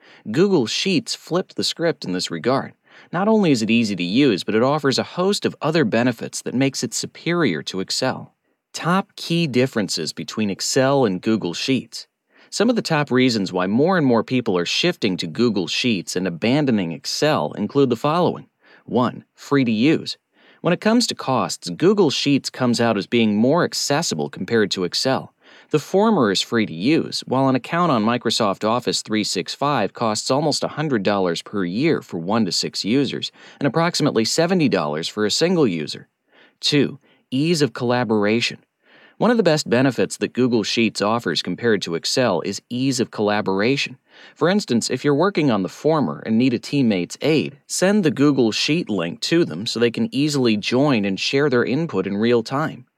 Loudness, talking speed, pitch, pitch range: -20 LUFS, 180 wpm, 125 Hz, 110-155 Hz